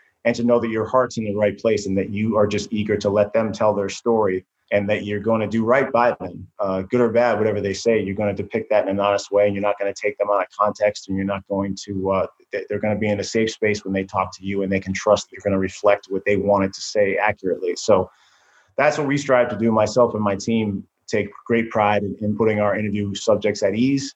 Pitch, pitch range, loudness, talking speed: 105 Hz, 100-115 Hz, -21 LUFS, 265 wpm